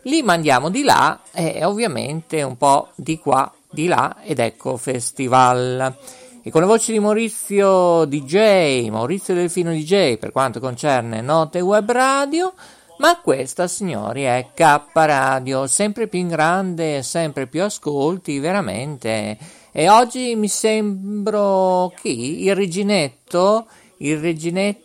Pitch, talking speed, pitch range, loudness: 175 Hz, 135 wpm, 140-205 Hz, -18 LUFS